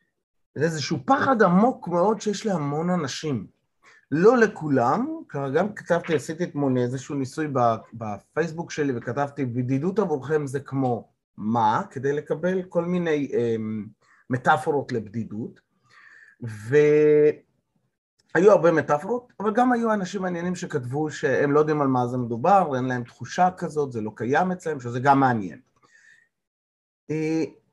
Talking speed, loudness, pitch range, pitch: 130 wpm, -23 LUFS, 125-175 Hz, 150 Hz